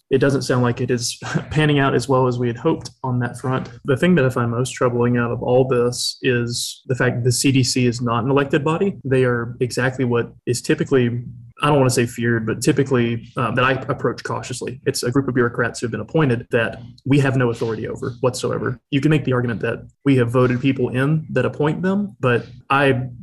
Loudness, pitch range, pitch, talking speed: -19 LUFS, 120-135 Hz, 125 Hz, 235 wpm